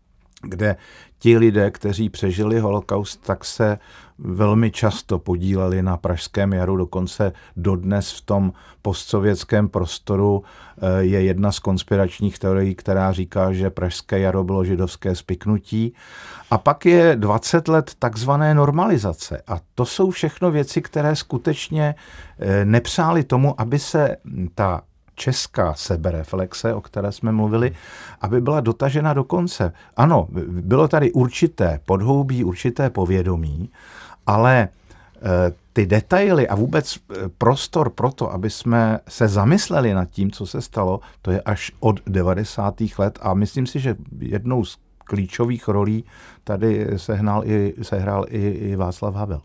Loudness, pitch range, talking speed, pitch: -20 LUFS, 95-120 Hz, 130 wpm, 105 Hz